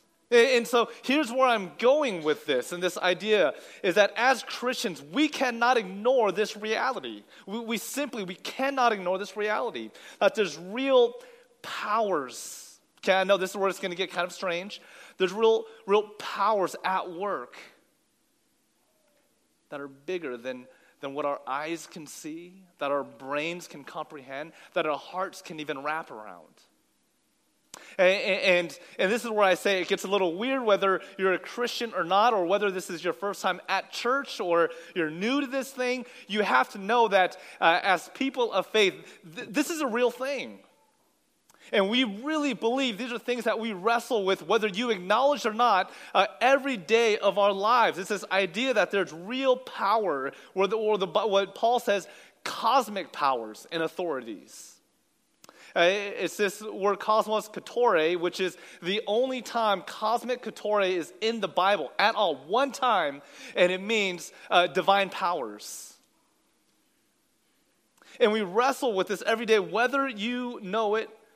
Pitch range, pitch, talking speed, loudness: 185-240 Hz, 205 Hz, 170 wpm, -27 LUFS